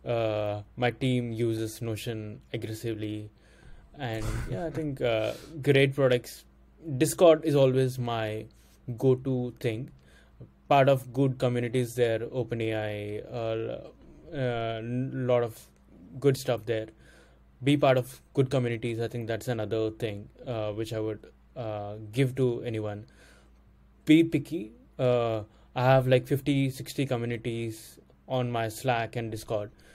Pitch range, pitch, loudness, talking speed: 110-130 Hz, 120 Hz, -29 LUFS, 130 wpm